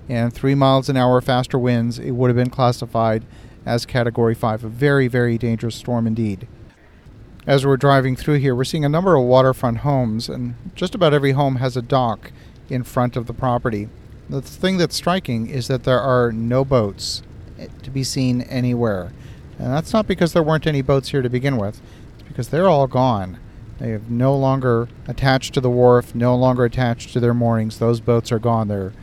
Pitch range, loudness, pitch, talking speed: 115-135 Hz, -19 LUFS, 125 Hz, 200 wpm